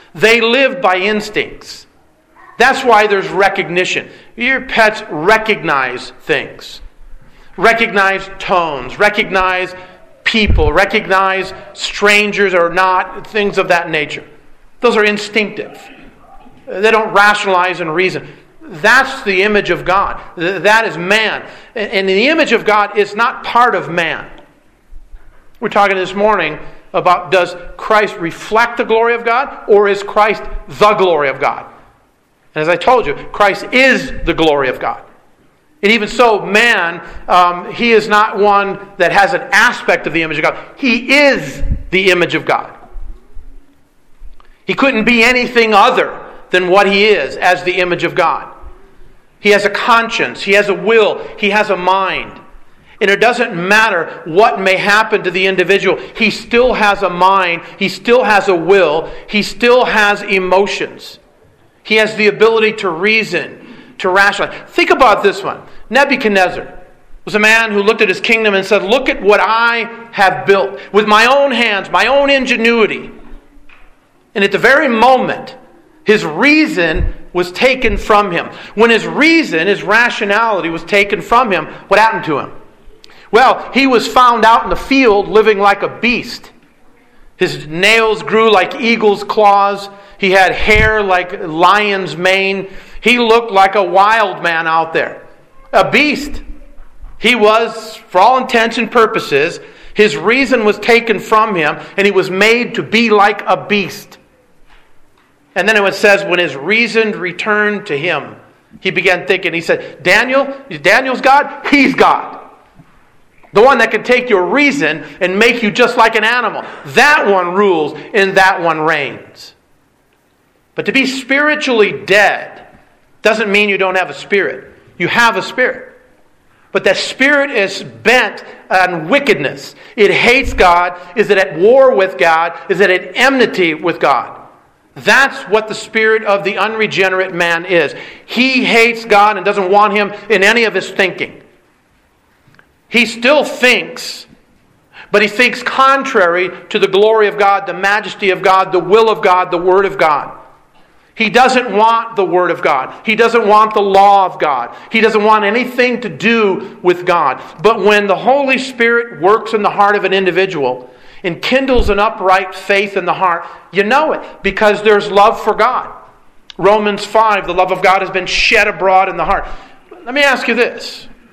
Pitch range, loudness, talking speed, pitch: 190-230 Hz, -11 LUFS, 160 wpm, 205 Hz